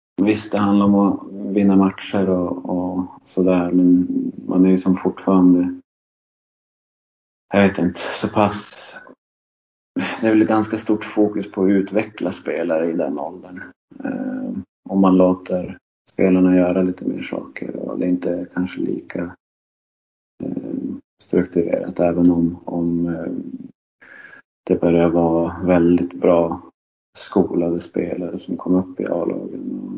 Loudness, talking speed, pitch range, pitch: -19 LUFS, 135 wpm, 90-100 Hz, 90 Hz